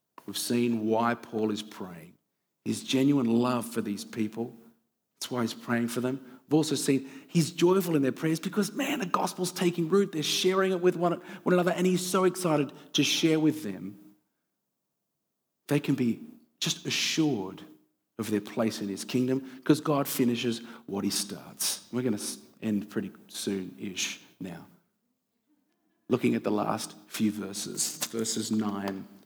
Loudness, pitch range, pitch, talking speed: -29 LUFS, 110-170 Hz, 130 Hz, 165 wpm